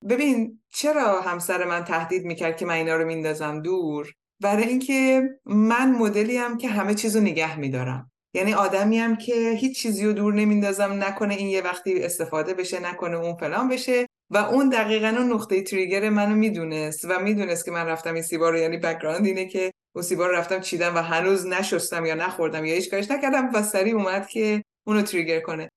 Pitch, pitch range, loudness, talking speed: 190 Hz, 170-220 Hz, -23 LUFS, 190 wpm